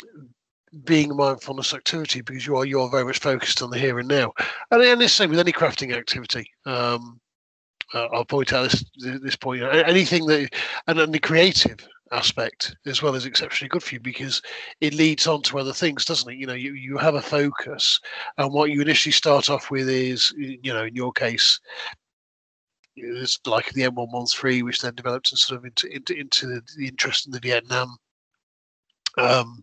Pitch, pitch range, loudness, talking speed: 135 Hz, 125-145 Hz, -21 LUFS, 205 wpm